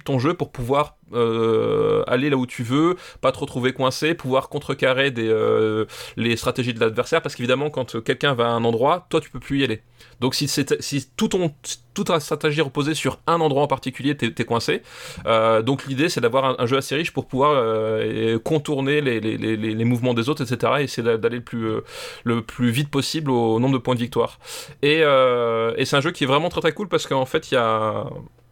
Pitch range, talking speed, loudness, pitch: 115-150 Hz, 230 wpm, -21 LUFS, 130 Hz